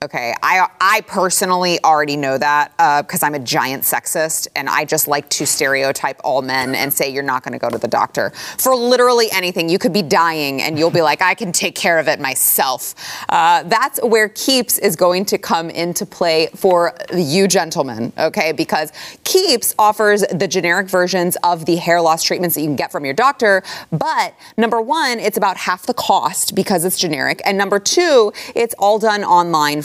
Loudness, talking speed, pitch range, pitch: -15 LUFS, 195 wpm, 155-205 Hz, 180 Hz